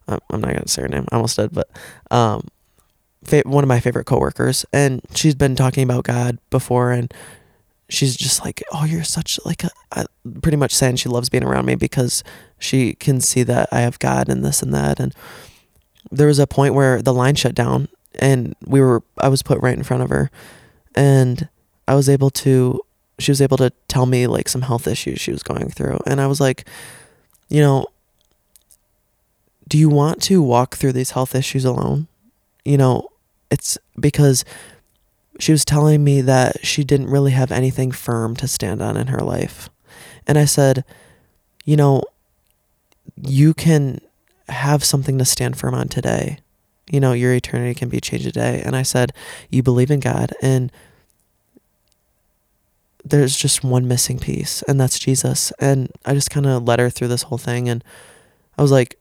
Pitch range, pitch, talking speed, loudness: 125-140 Hz, 130 Hz, 185 wpm, -17 LUFS